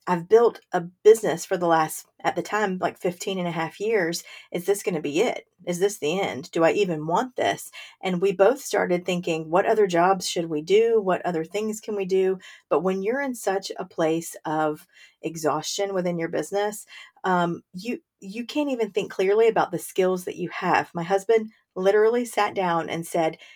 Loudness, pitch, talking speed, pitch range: -24 LUFS, 190 Hz, 205 wpm, 170-215 Hz